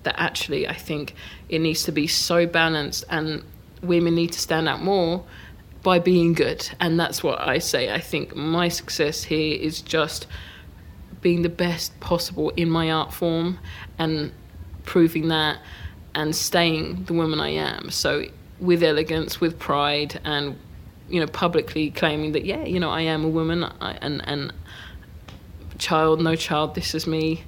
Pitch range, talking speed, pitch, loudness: 150-170 Hz, 165 wpm, 160 Hz, -23 LUFS